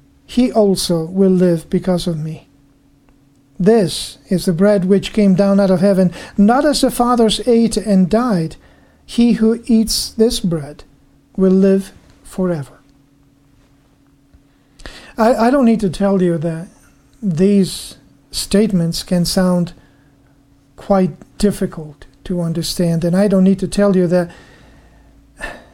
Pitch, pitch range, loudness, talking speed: 185 Hz, 160-205 Hz, -15 LUFS, 130 wpm